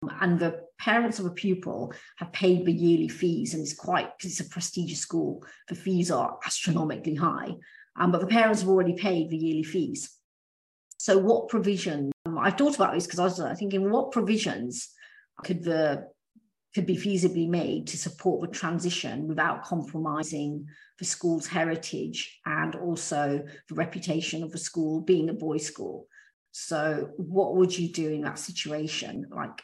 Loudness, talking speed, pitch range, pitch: -28 LUFS, 170 wpm, 160-190 Hz, 175 Hz